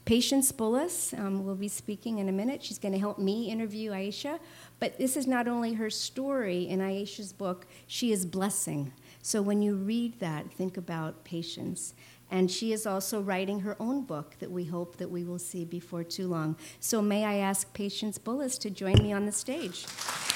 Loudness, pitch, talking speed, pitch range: -32 LUFS, 200 Hz, 195 wpm, 185-225 Hz